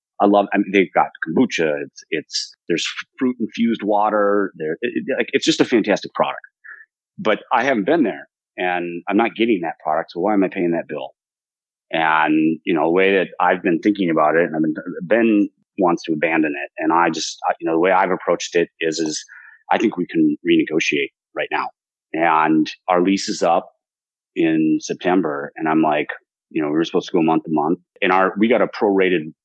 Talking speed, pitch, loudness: 210 wpm, 110 Hz, -19 LUFS